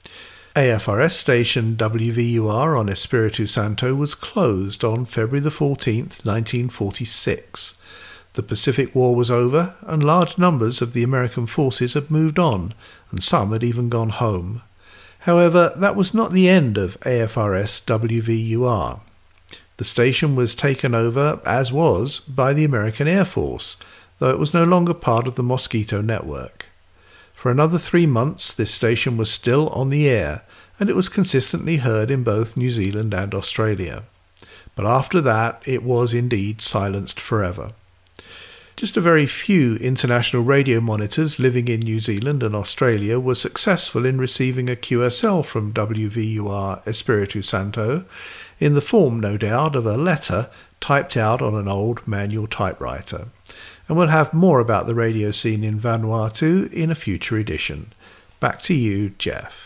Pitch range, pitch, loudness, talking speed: 110-140 Hz, 120 Hz, -19 LUFS, 155 wpm